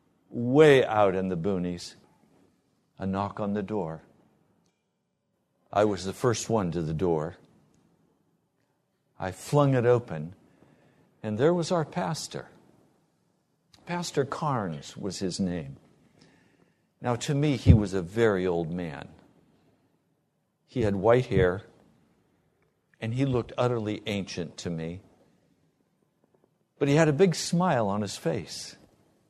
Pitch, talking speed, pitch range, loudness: 110 Hz, 125 wpm, 90-145 Hz, -27 LUFS